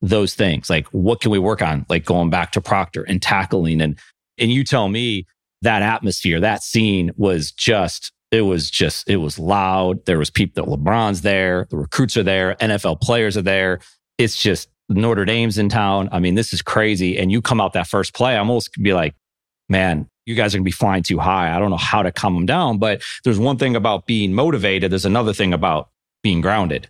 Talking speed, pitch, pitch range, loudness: 215 wpm, 100 Hz, 90-110 Hz, -18 LUFS